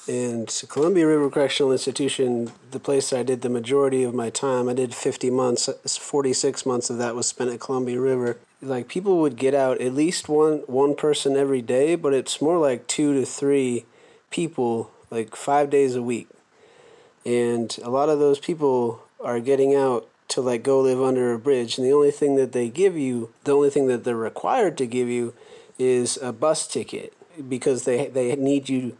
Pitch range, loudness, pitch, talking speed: 120-140 Hz, -22 LUFS, 130 Hz, 195 wpm